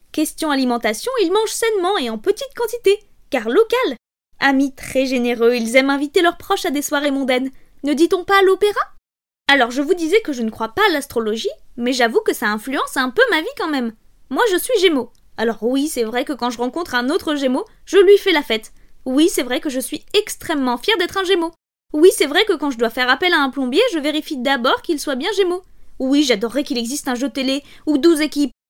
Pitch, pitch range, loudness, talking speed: 295 Hz, 260-385 Hz, -18 LUFS, 230 wpm